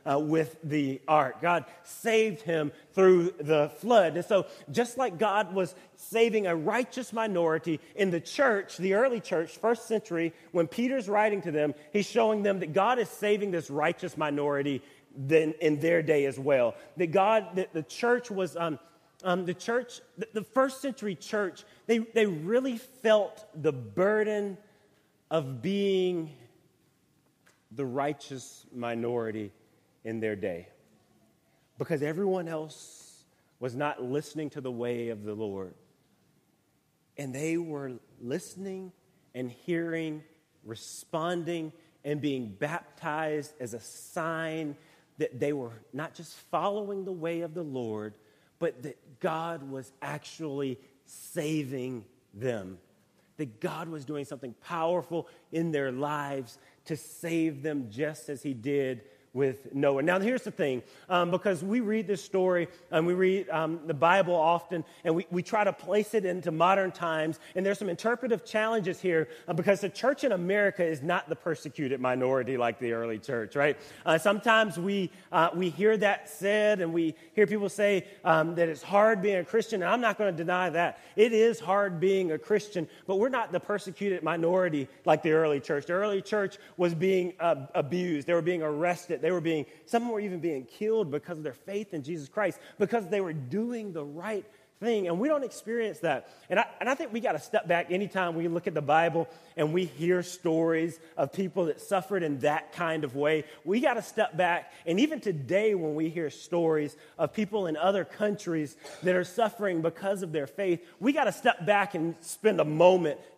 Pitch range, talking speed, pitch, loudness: 150-200 Hz, 175 wpm, 170 Hz, -29 LUFS